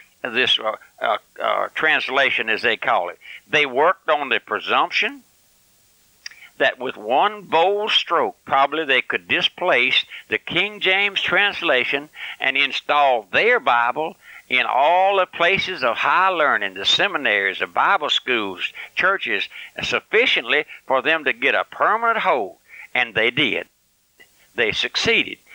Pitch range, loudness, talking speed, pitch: 165-205 Hz, -19 LUFS, 135 wpm, 185 Hz